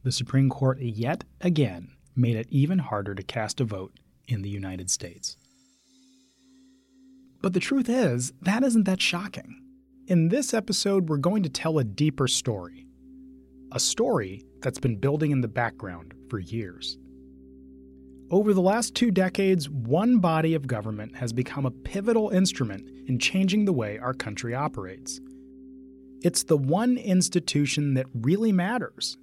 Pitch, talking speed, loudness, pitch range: 135 Hz, 150 wpm, -26 LUFS, 115-190 Hz